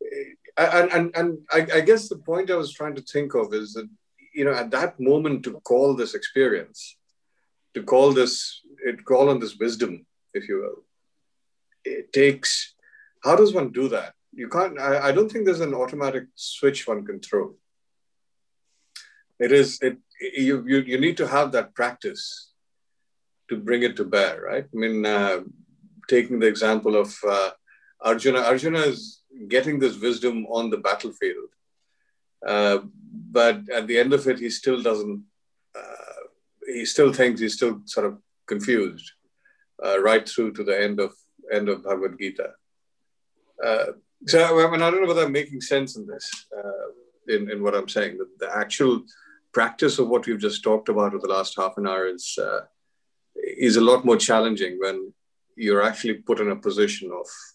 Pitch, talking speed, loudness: 145 Hz, 175 wpm, -22 LUFS